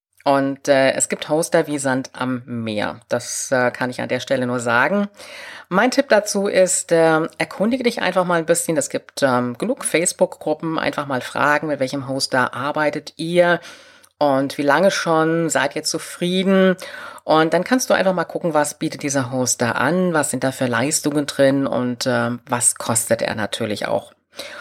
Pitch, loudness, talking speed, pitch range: 150 Hz, -19 LUFS, 180 wpm, 135-175 Hz